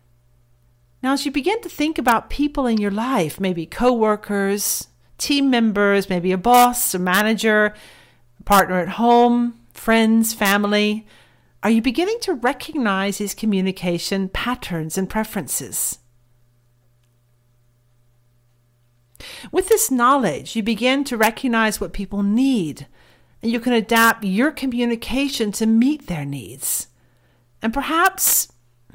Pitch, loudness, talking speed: 210 Hz, -19 LUFS, 120 wpm